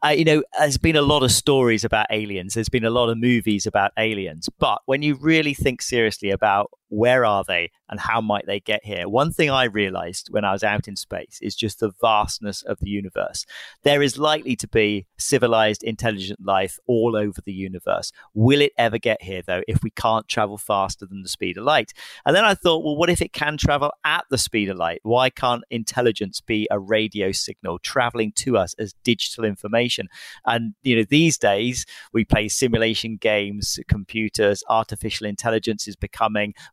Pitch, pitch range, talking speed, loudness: 110 Hz, 105-130 Hz, 200 wpm, -21 LUFS